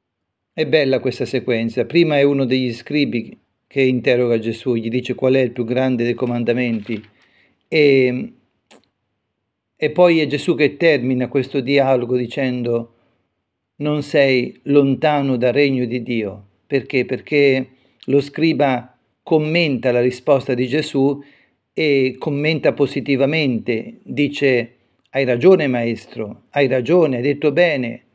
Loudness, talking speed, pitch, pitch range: -18 LUFS, 125 wpm, 130 Hz, 120-145 Hz